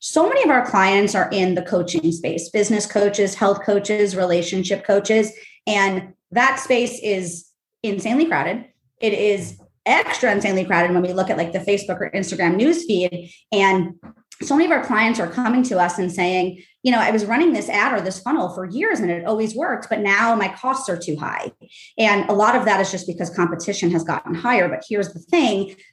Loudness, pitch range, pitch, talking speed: -19 LUFS, 180-230 Hz, 200 Hz, 205 wpm